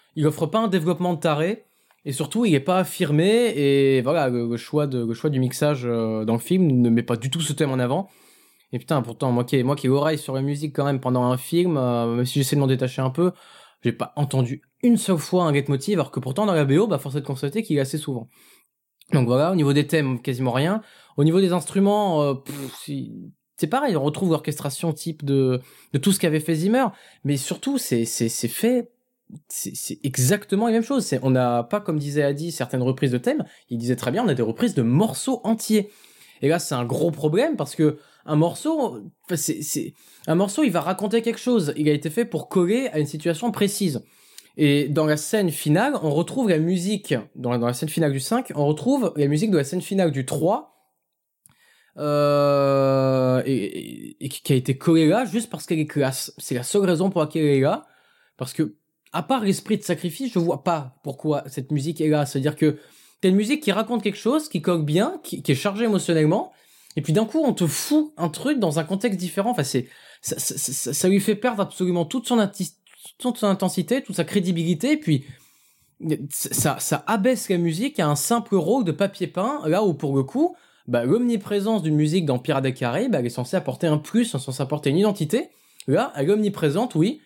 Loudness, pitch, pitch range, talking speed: -22 LUFS, 155 Hz, 140-200 Hz, 230 wpm